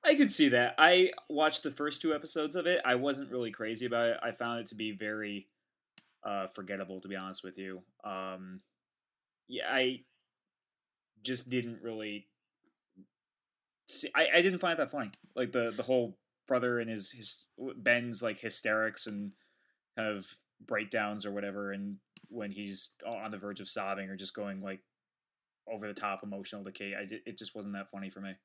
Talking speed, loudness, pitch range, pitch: 185 wpm, -33 LUFS, 100-125 Hz, 110 Hz